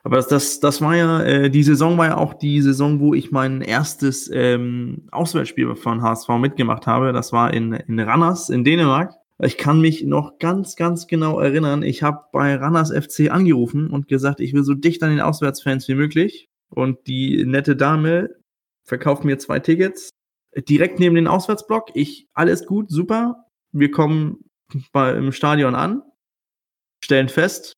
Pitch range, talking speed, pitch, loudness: 135-170 Hz, 175 wpm, 150 Hz, -18 LUFS